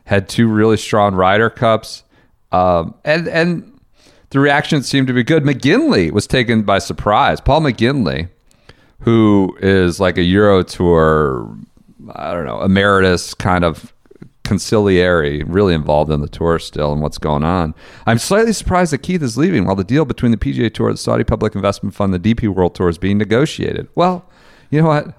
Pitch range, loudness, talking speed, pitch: 90-130 Hz, -15 LUFS, 180 wpm, 105 Hz